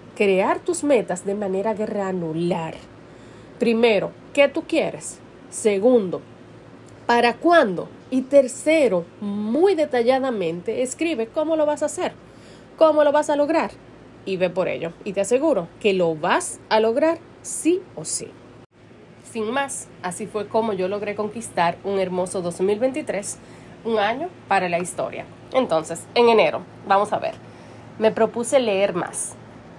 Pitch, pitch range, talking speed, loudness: 220 Hz, 195-285 Hz, 140 wpm, -21 LUFS